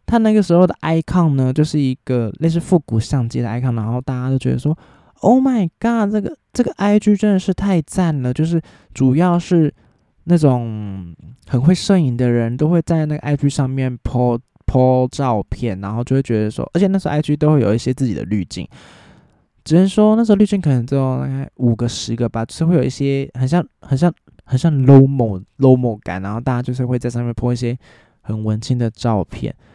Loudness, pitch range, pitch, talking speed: -17 LUFS, 120-170 Hz, 135 Hz, 330 characters per minute